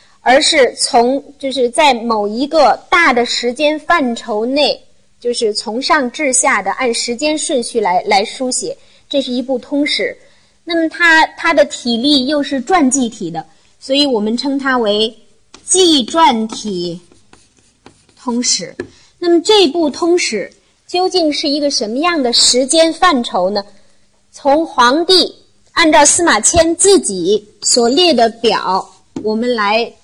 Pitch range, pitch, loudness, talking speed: 235-325 Hz, 275 Hz, -13 LUFS, 200 characters per minute